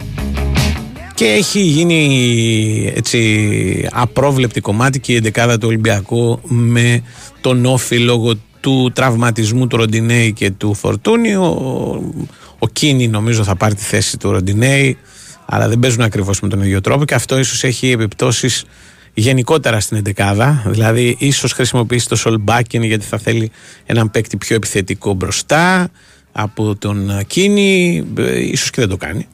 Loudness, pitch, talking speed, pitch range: -14 LUFS, 115 Hz, 140 wpm, 110-130 Hz